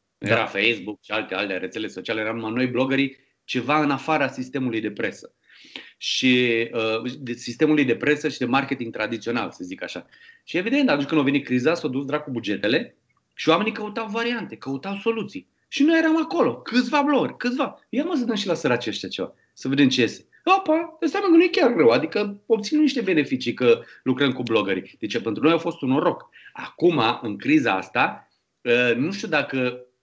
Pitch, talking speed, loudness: 145 Hz, 195 wpm, -22 LUFS